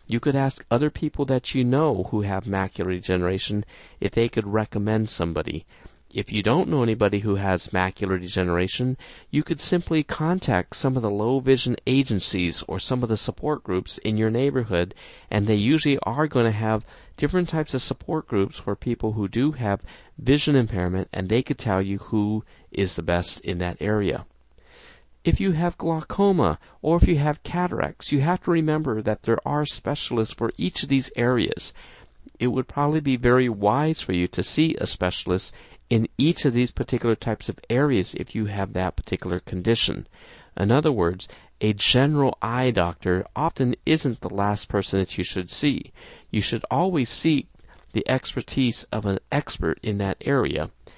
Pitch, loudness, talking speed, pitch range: 110 Hz, -24 LUFS, 180 wpm, 95-135 Hz